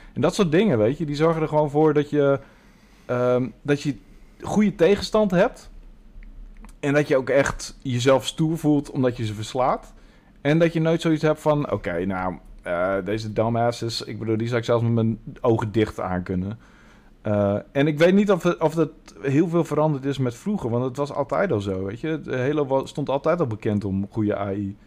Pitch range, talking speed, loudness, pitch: 110-155 Hz, 210 wpm, -23 LUFS, 135 Hz